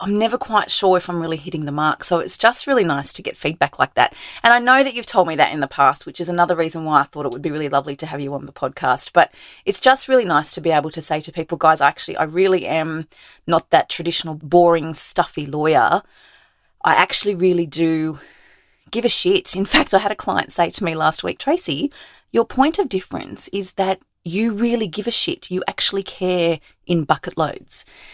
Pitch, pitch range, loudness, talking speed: 175 Hz, 160-225 Hz, -18 LUFS, 230 wpm